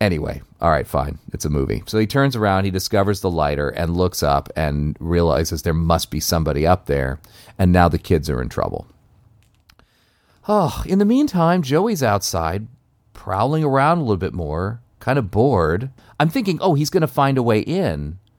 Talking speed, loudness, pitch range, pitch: 185 wpm, -19 LUFS, 85-125 Hz, 100 Hz